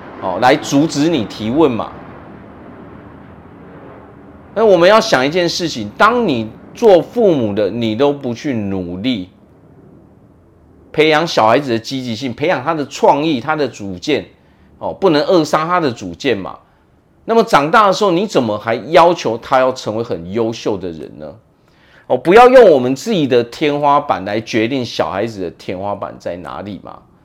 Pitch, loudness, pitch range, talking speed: 125 Hz, -14 LUFS, 105-150 Hz, 235 characters per minute